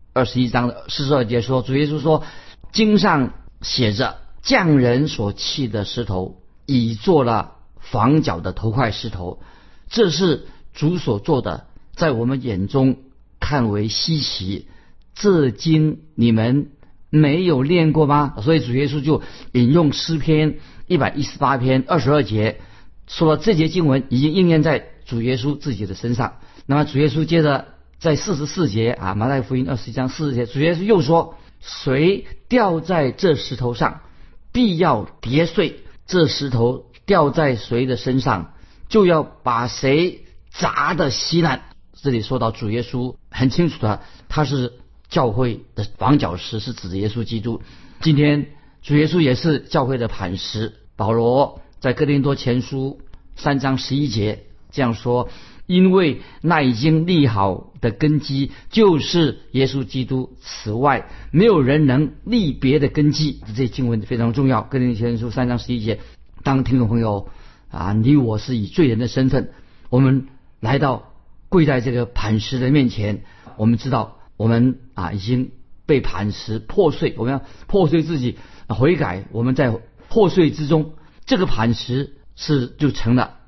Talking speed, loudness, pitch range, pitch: 230 characters per minute, -19 LUFS, 115-150 Hz, 130 Hz